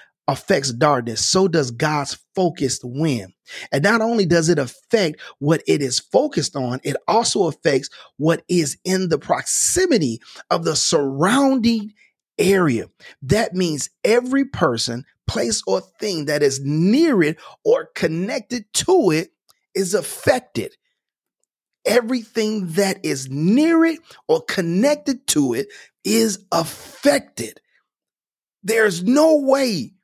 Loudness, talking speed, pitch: -19 LUFS, 120 wpm, 190 Hz